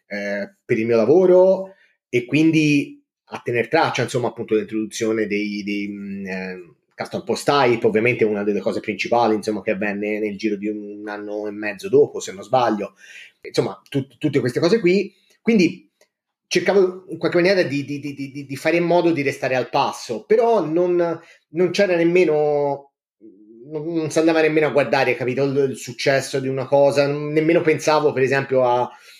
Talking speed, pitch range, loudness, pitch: 170 wpm, 115-170 Hz, -20 LUFS, 140 Hz